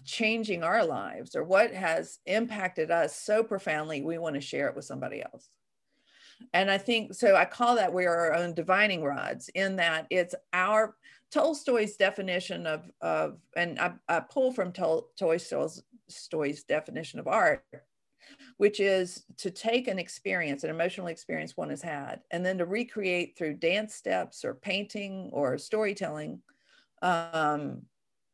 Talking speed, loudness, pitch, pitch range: 155 wpm, -29 LUFS, 185 Hz, 170-215 Hz